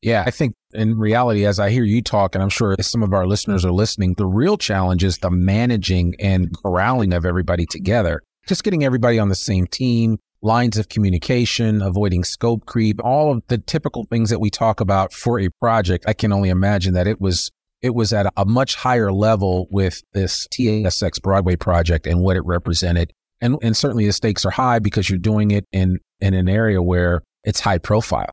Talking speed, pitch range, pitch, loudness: 210 wpm, 95-115 Hz, 105 Hz, -18 LUFS